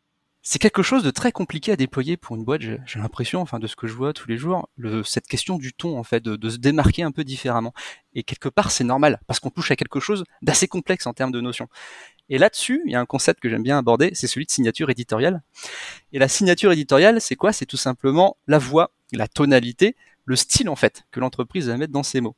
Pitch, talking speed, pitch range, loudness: 135 Hz, 250 wpm, 120-170 Hz, -21 LUFS